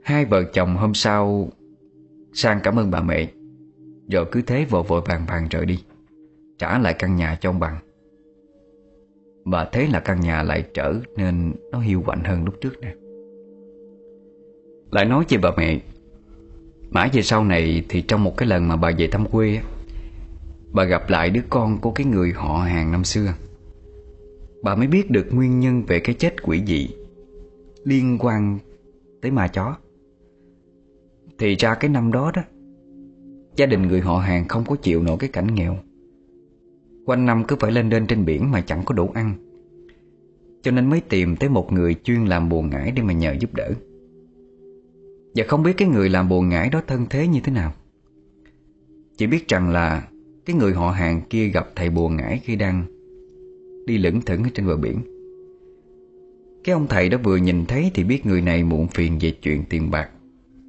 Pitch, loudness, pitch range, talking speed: 105 Hz, -21 LUFS, 85-145 Hz, 185 wpm